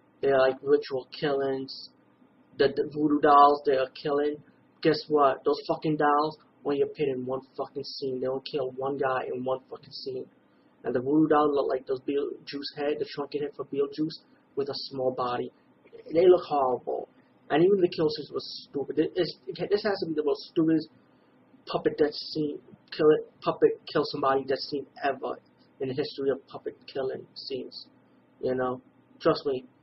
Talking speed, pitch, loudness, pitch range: 185 wpm, 145 Hz, -28 LUFS, 135-160 Hz